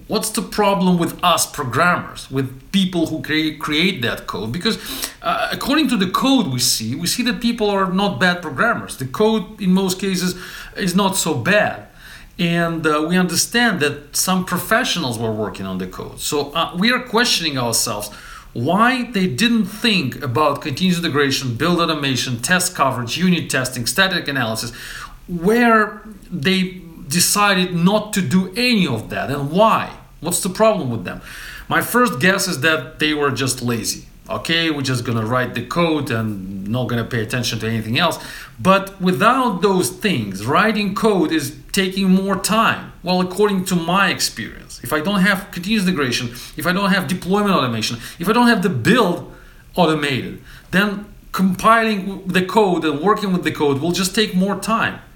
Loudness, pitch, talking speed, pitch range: -18 LUFS, 180 Hz, 175 wpm, 145-200 Hz